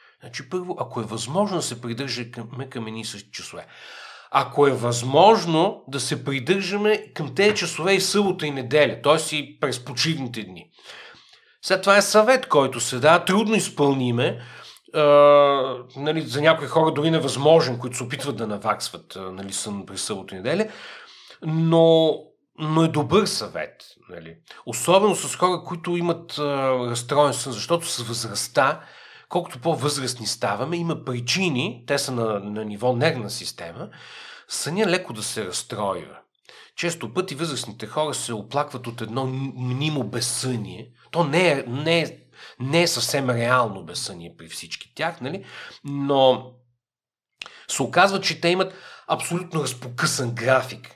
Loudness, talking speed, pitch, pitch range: -22 LUFS, 145 wpm, 140 Hz, 120-165 Hz